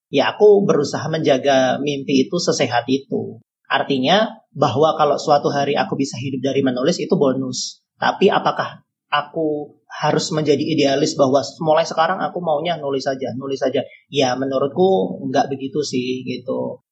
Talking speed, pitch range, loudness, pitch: 145 wpm, 135-155 Hz, -19 LUFS, 145 Hz